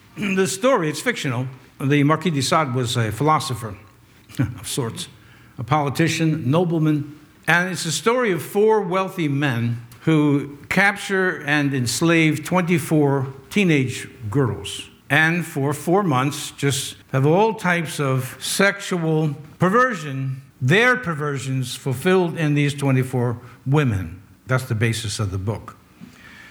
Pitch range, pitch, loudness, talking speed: 130-170 Hz, 145 Hz, -20 LUFS, 125 wpm